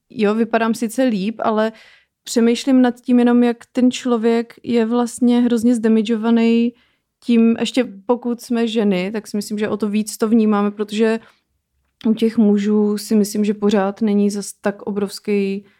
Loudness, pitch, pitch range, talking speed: -18 LUFS, 225 Hz, 210-235 Hz, 160 wpm